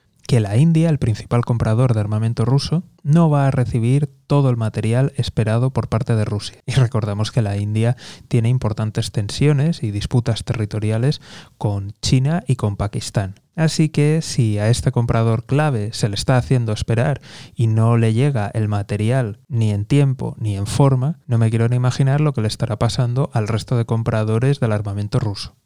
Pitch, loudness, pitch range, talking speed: 120 Hz, -19 LUFS, 110-135 Hz, 180 wpm